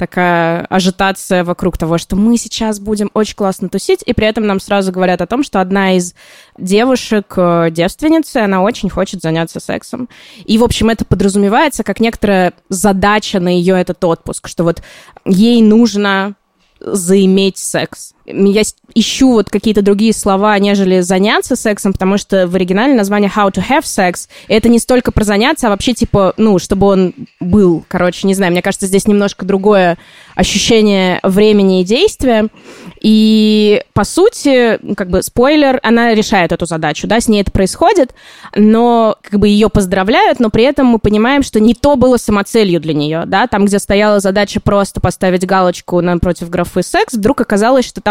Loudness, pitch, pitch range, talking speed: -11 LUFS, 205 Hz, 190-225 Hz, 170 wpm